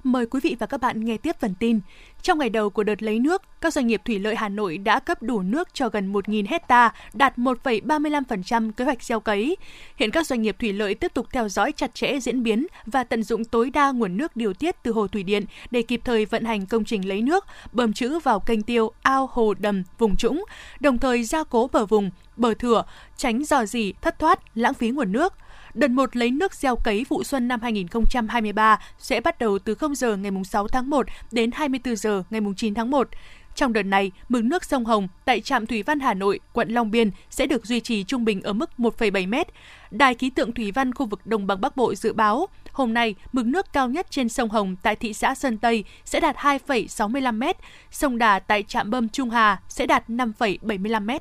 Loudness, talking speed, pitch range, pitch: -23 LUFS, 225 wpm, 220-270 Hz, 235 Hz